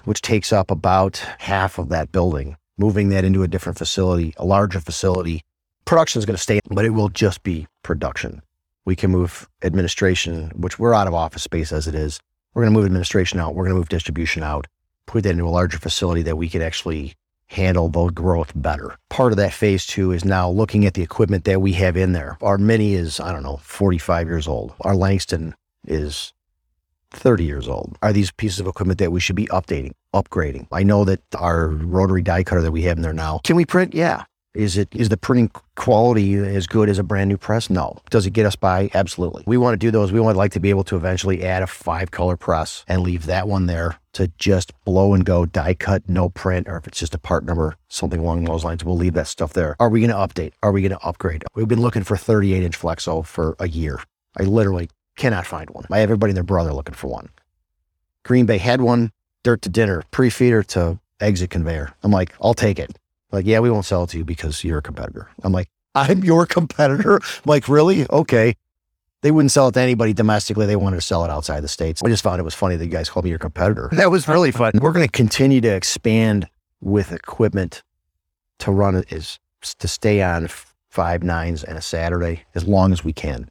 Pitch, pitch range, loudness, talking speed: 95 Hz, 85-105 Hz, -19 LUFS, 230 wpm